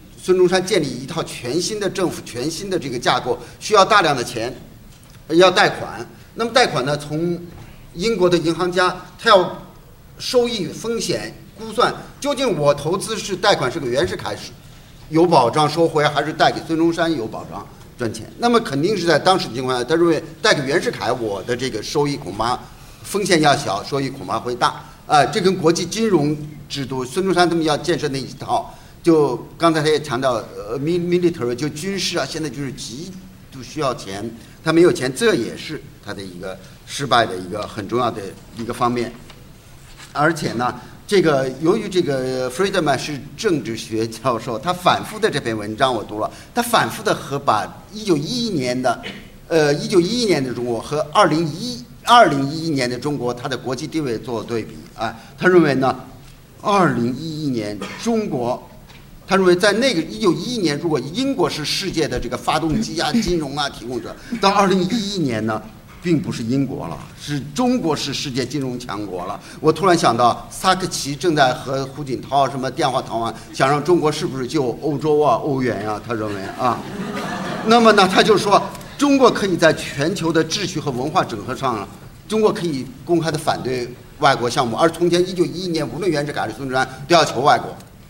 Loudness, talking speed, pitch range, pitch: -19 LUFS, 290 characters per minute, 130-180 Hz, 155 Hz